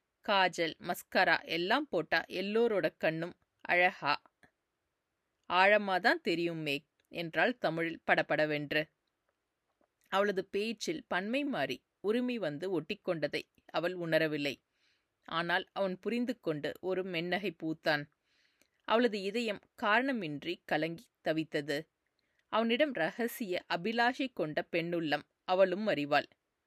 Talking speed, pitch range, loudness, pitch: 90 wpm, 160-215 Hz, -33 LUFS, 180 Hz